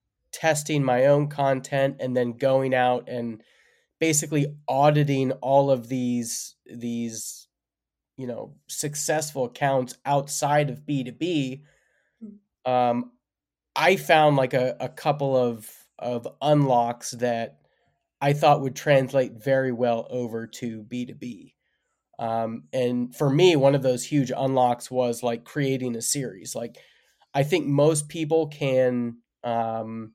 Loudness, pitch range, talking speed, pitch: -24 LUFS, 120-145 Hz, 125 wpm, 130 Hz